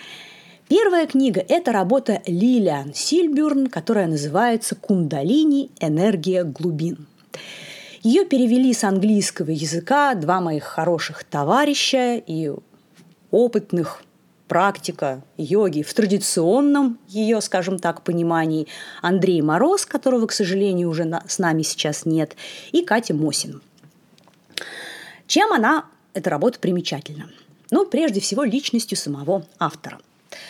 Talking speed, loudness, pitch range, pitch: 105 wpm, -20 LUFS, 165-245 Hz, 190 Hz